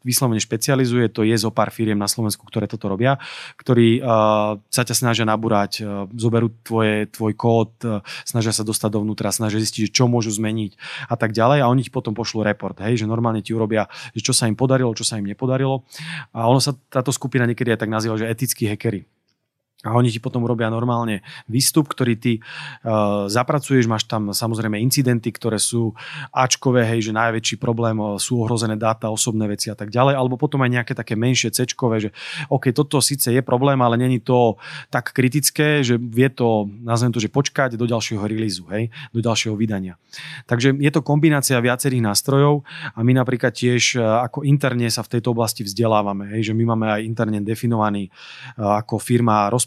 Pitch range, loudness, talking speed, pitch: 110-130 Hz, -20 LUFS, 190 wpm, 115 Hz